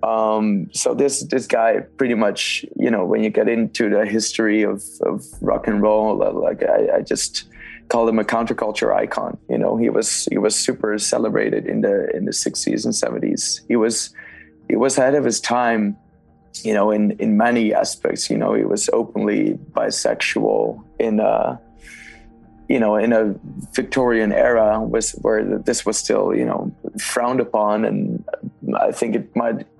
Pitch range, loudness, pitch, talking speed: 105-115 Hz, -19 LUFS, 110 Hz, 175 wpm